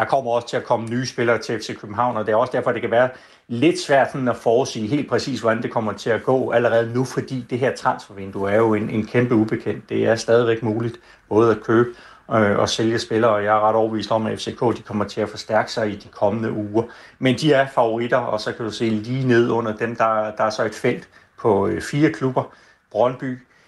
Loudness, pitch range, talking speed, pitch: -21 LUFS, 110-125 Hz, 245 wpm, 115 Hz